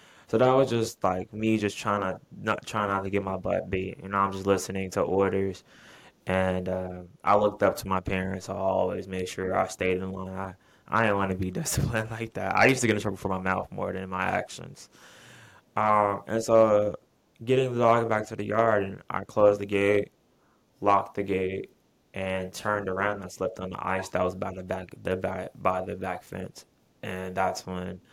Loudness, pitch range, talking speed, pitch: -27 LUFS, 95-105 Hz, 220 wpm, 95 Hz